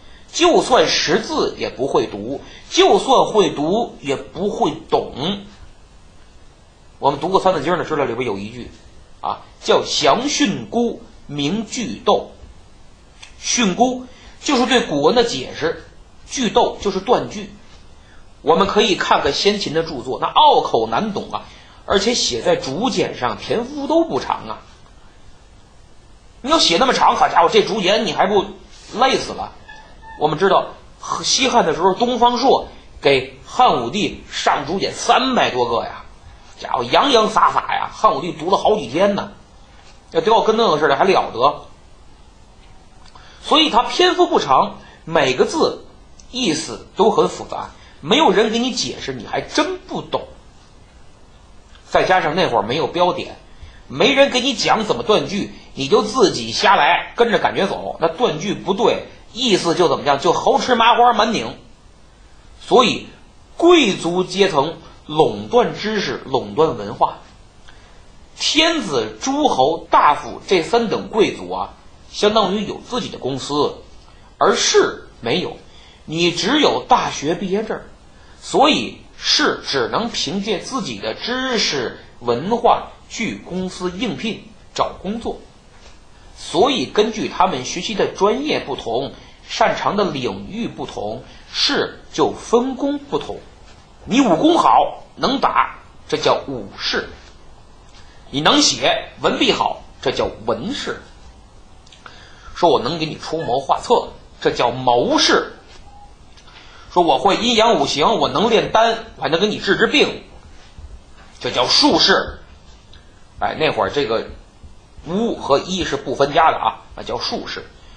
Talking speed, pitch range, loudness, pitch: 205 characters per minute, 160-275 Hz, -17 LUFS, 225 Hz